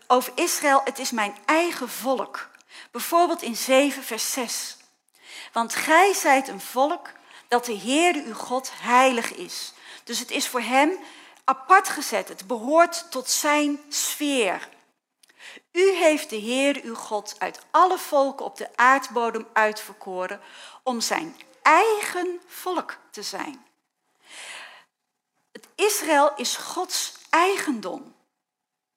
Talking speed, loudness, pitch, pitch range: 125 wpm, -23 LUFS, 270 Hz, 240-325 Hz